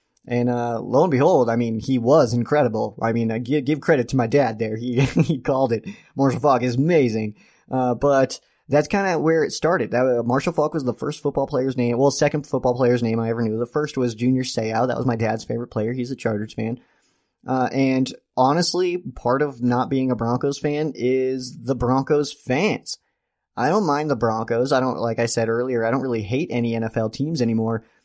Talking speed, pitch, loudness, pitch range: 220 wpm, 125 Hz, -21 LUFS, 115-140 Hz